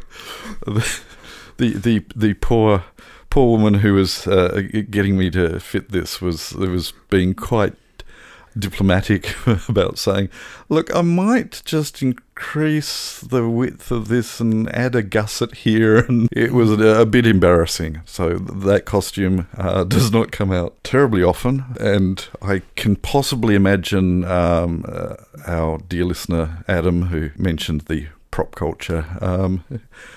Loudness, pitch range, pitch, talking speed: -19 LUFS, 90-115 Hz, 100 Hz, 135 wpm